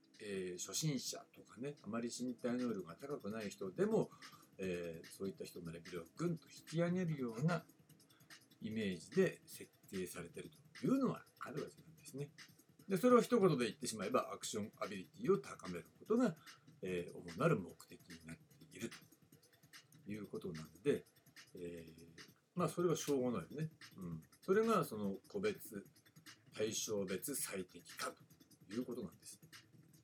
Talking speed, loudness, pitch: 325 characters per minute, -41 LUFS, 145 Hz